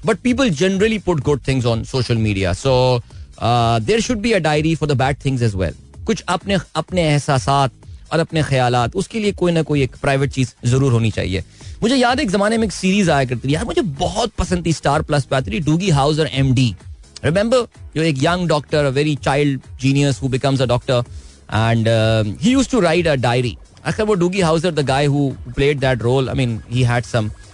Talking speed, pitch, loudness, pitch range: 210 wpm, 140 Hz, -18 LUFS, 120-165 Hz